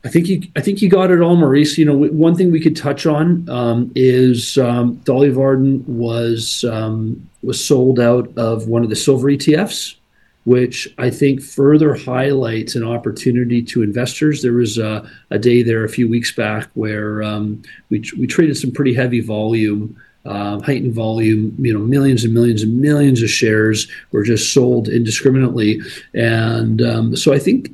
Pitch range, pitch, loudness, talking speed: 115-140 Hz, 120 Hz, -15 LUFS, 175 wpm